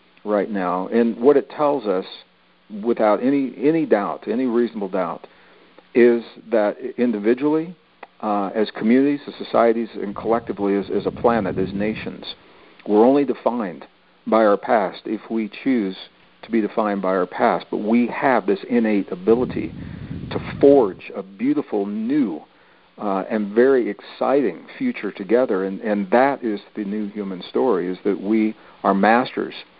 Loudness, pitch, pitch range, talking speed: -20 LUFS, 110 Hz, 100-135 Hz, 150 wpm